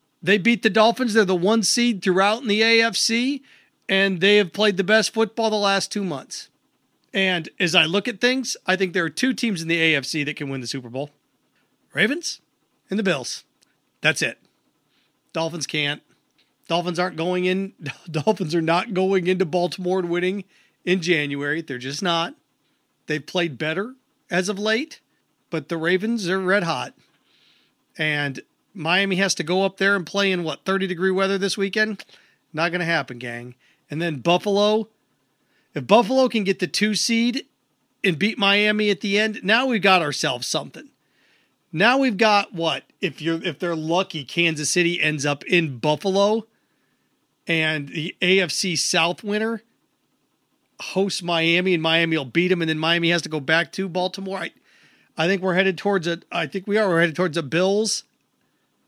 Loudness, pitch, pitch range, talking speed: -21 LUFS, 185 Hz, 165-210 Hz, 175 wpm